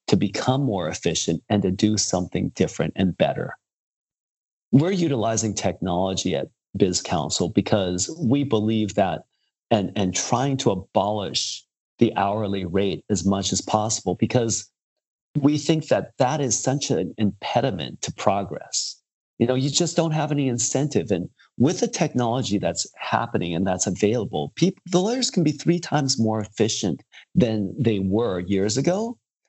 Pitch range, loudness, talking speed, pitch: 100-140 Hz, -23 LUFS, 155 wpm, 110 Hz